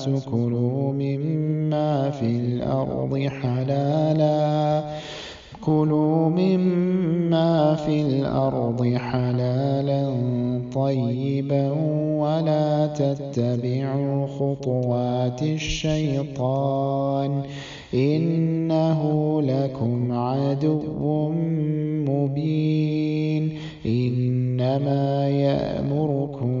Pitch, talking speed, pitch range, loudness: 140 Hz, 40 wpm, 130-155 Hz, -23 LUFS